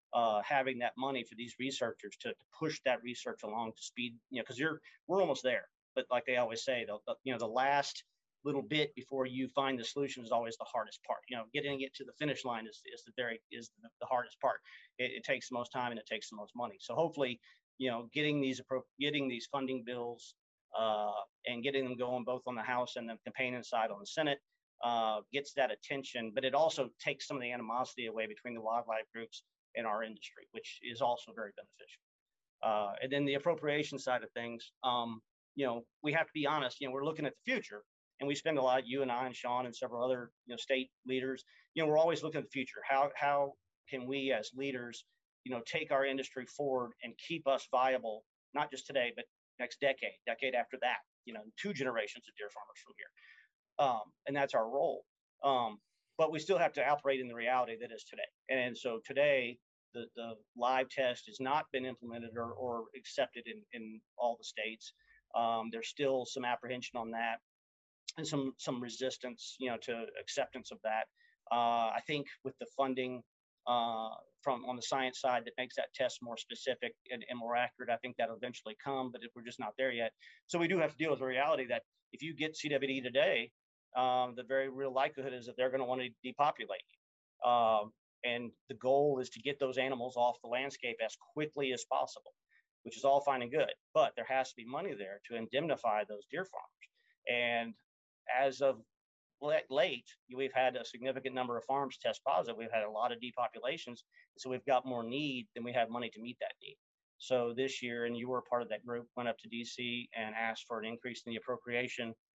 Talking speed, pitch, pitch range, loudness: 220 wpm, 125 Hz, 120-135 Hz, -37 LUFS